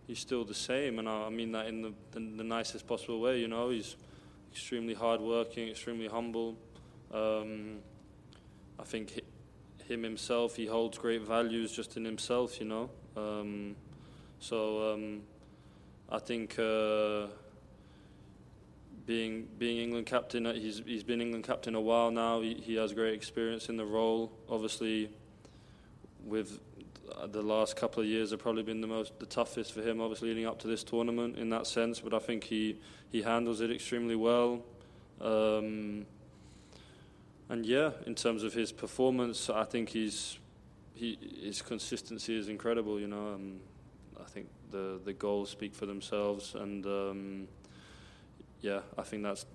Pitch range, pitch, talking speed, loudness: 105-115 Hz, 110 Hz, 160 wpm, -36 LUFS